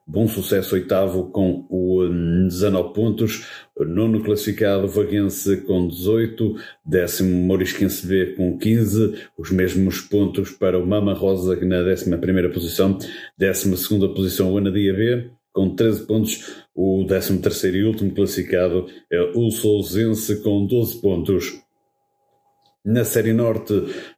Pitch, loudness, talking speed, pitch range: 100 Hz, -20 LUFS, 130 wpm, 95-110 Hz